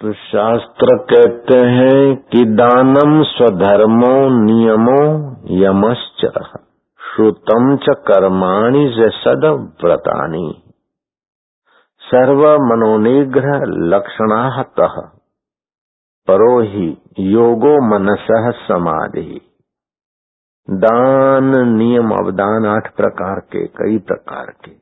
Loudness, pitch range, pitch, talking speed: -12 LUFS, 105-135 Hz, 115 Hz, 70 wpm